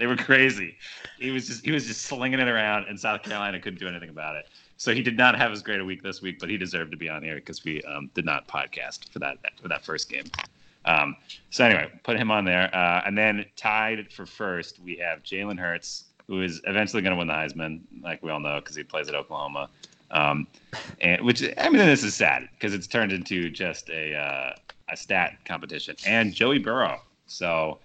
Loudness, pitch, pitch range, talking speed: -25 LUFS, 95 Hz, 85-110 Hz, 230 wpm